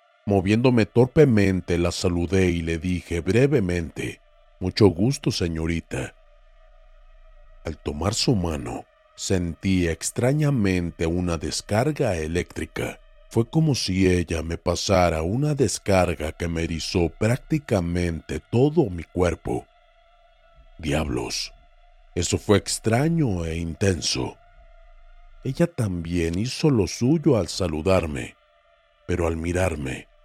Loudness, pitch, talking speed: -23 LUFS, 100 Hz, 100 wpm